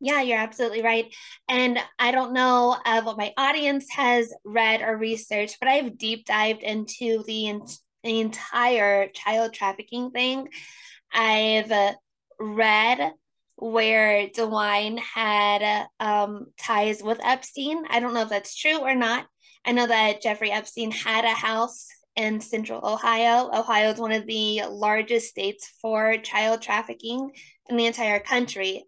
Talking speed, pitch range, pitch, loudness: 145 wpm, 215-245 Hz, 225 Hz, -23 LUFS